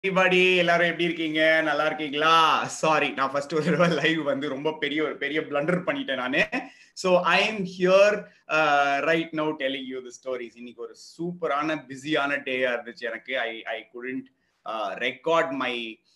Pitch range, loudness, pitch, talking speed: 130-165 Hz, -24 LUFS, 155 Hz, 140 wpm